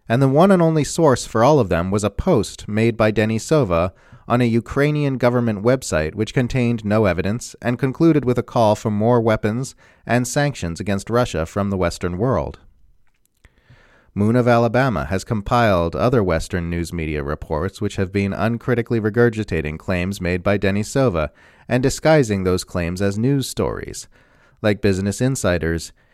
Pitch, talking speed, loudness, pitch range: 110 Hz, 160 wpm, -19 LUFS, 95-125 Hz